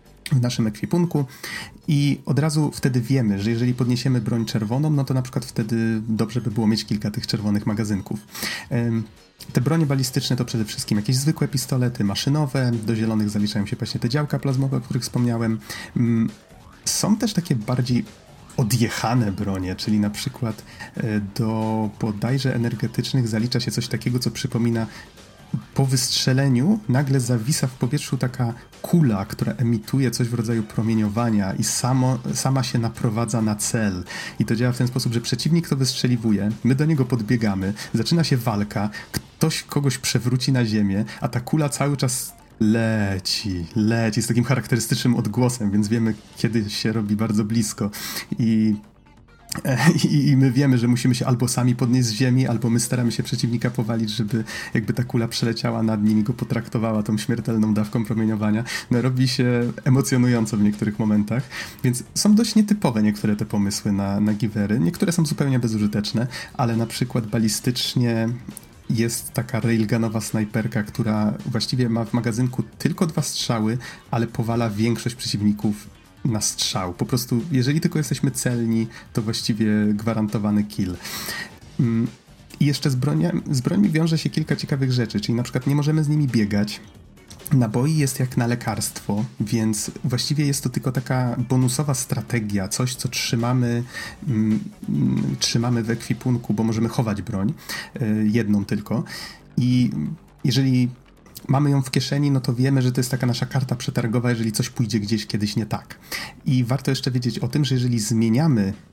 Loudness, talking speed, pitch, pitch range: -22 LUFS, 160 wpm, 120 Hz, 110-130 Hz